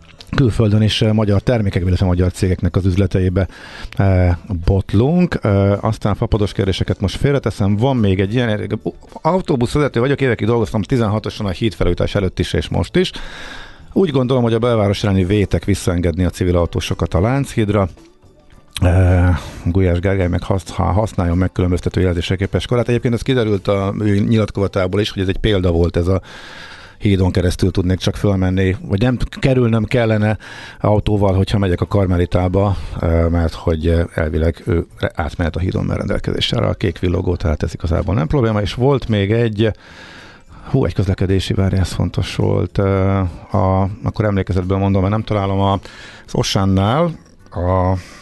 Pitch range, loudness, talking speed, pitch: 90-110 Hz, -17 LUFS, 155 wpm, 100 Hz